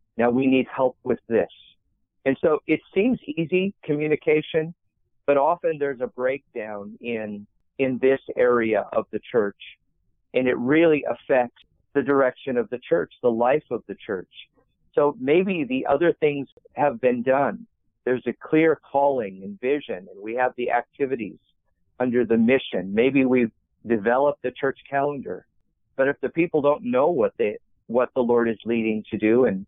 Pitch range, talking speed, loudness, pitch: 115-150 Hz, 165 wpm, -23 LUFS, 130 Hz